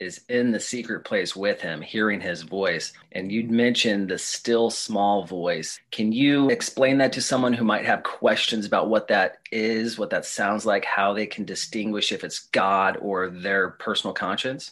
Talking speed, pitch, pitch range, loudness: 190 wpm, 115 Hz, 105-120 Hz, -24 LUFS